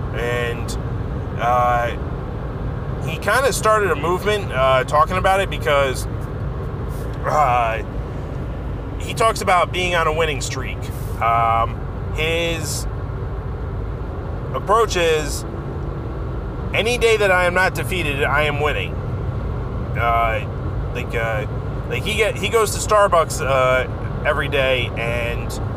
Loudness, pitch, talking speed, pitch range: -20 LUFS, 120 Hz, 115 wpm, 115-135 Hz